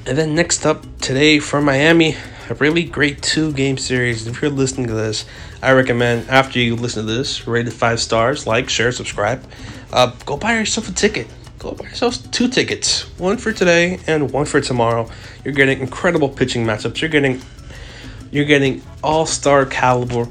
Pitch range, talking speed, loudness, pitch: 120-150 Hz, 175 wpm, -17 LUFS, 130 Hz